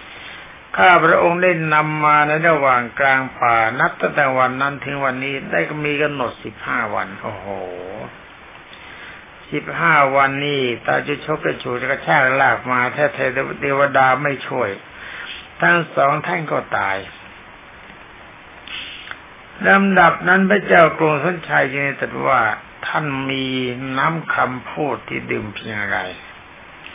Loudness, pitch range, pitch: -17 LUFS, 130-150 Hz, 140 Hz